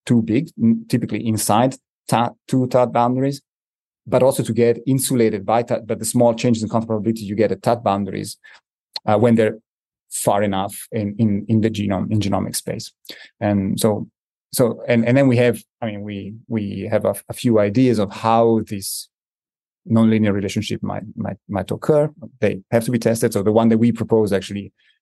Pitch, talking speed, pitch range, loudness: 115 Hz, 185 wpm, 105-120 Hz, -19 LUFS